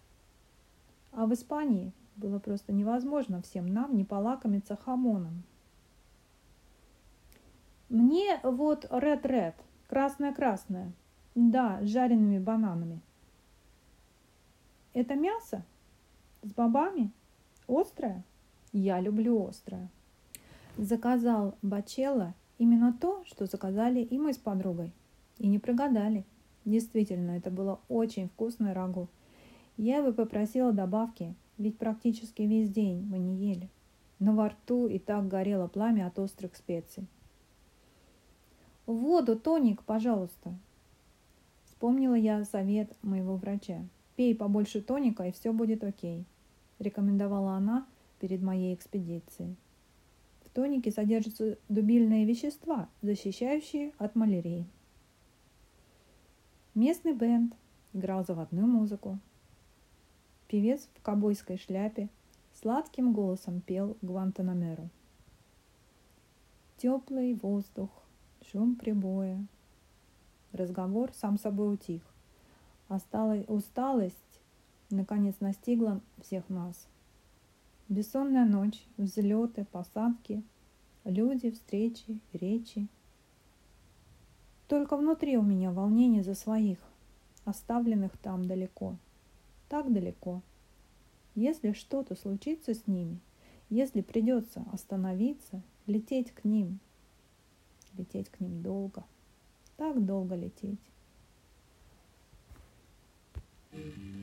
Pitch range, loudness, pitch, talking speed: 190-235 Hz, -32 LUFS, 210 Hz, 90 wpm